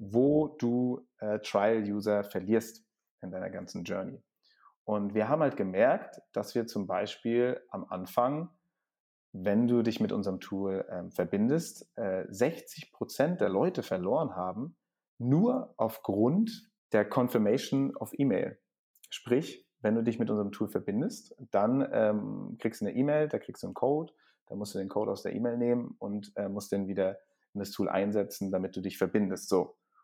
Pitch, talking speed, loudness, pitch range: 105 Hz, 170 wpm, -31 LUFS, 100-125 Hz